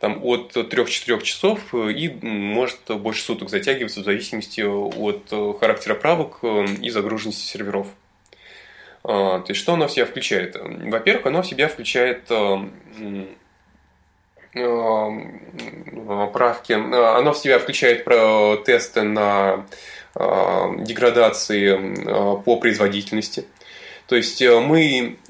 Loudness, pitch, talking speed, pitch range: -20 LUFS, 110 Hz, 95 wpm, 100-120 Hz